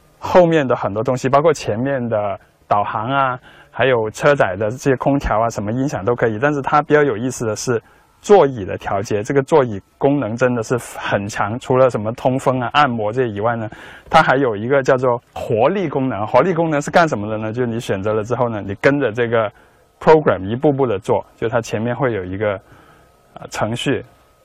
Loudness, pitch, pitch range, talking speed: -17 LUFS, 125 Hz, 110-140 Hz, 315 characters per minute